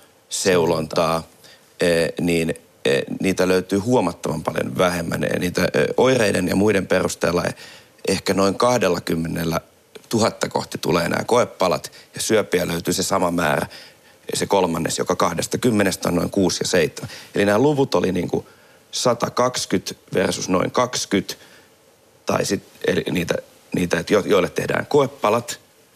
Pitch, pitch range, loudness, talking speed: 95 Hz, 85-120 Hz, -20 LUFS, 125 wpm